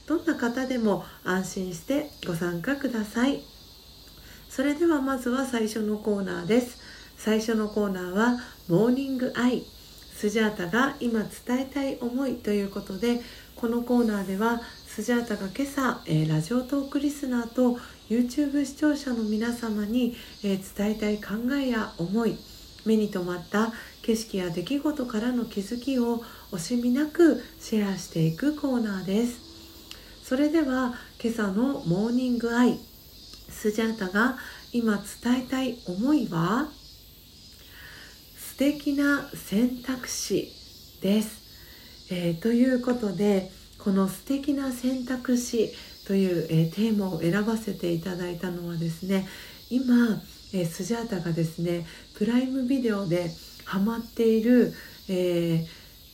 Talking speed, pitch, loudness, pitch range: 265 characters per minute, 230 Hz, -27 LUFS, 195-255 Hz